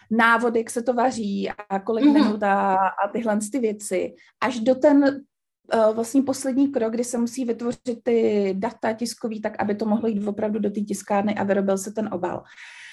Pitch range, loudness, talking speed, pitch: 205-240 Hz, -23 LUFS, 185 wpm, 225 Hz